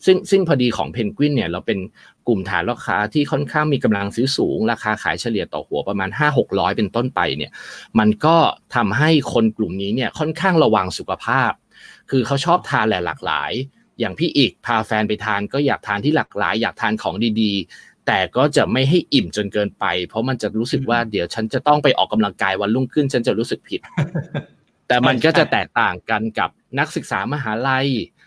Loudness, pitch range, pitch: -19 LUFS, 105-140 Hz, 120 Hz